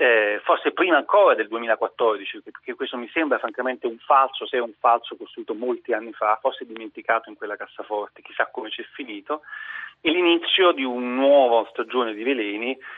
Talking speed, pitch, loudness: 180 wpm, 175 Hz, -22 LUFS